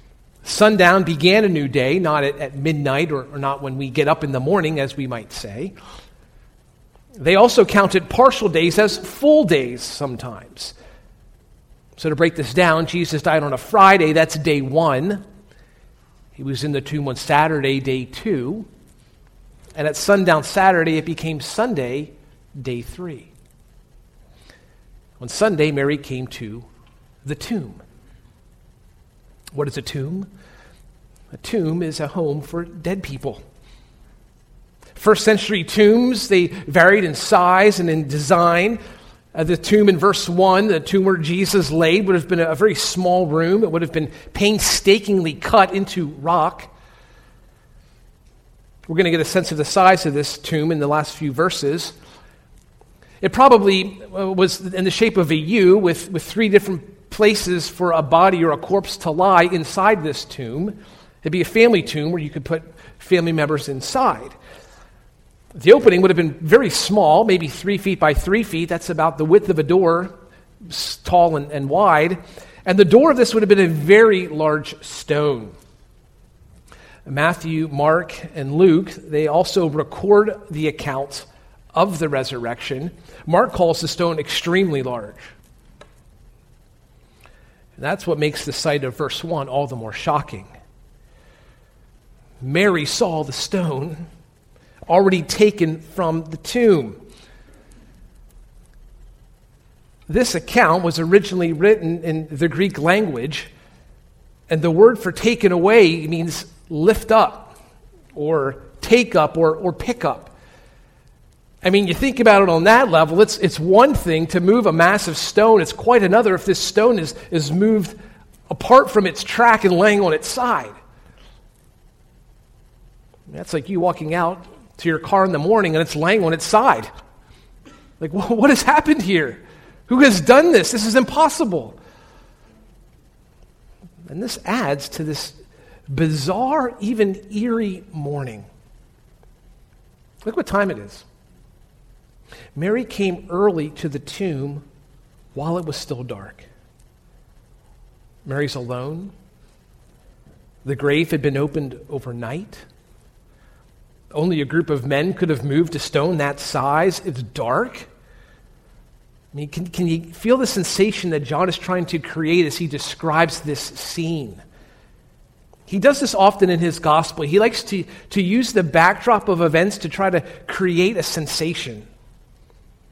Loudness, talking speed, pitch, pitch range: -17 LUFS, 145 wpm, 170 Hz, 150-195 Hz